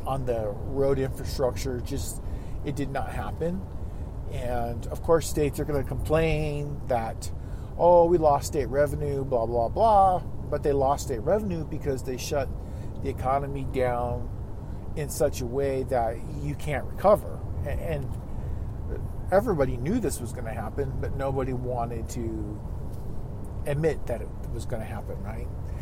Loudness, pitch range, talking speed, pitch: -28 LUFS, 110-140 Hz, 150 wpm, 125 Hz